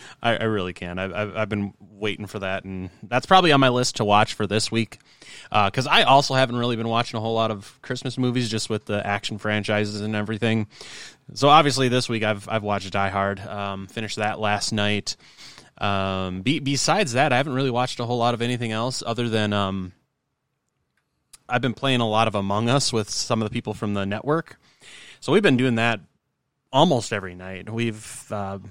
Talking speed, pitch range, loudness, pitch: 205 wpm, 105-125 Hz, -23 LUFS, 110 Hz